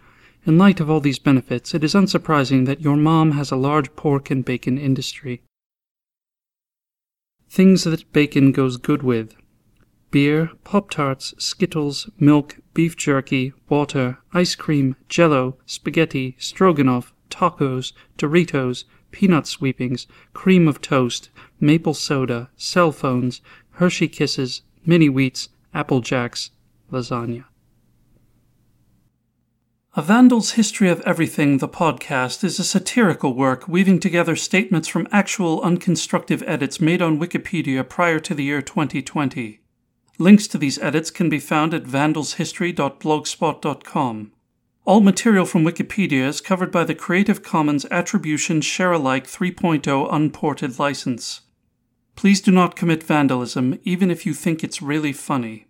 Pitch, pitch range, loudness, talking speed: 150 Hz, 130-175 Hz, -19 LUFS, 125 wpm